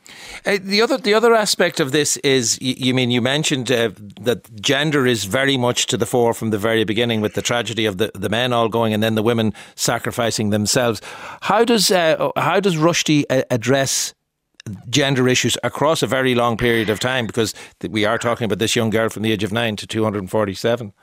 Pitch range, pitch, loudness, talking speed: 110-135 Hz, 120 Hz, -18 LUFS, 210 wpm